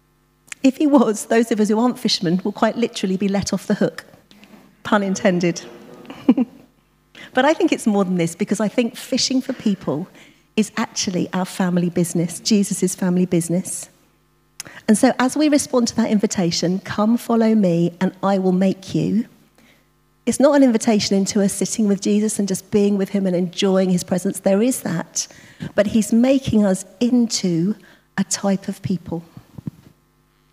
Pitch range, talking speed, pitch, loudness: 185-230 Hz, 170 wpm, 205 Hz, -19 LUFS